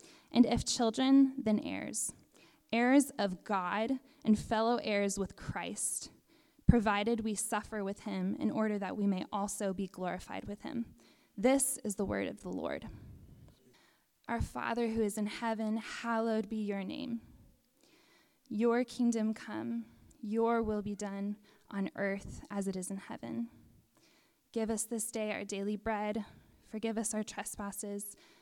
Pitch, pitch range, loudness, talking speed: 215 Hz, 200-235 Hz, -35 LUFS, 150 wpm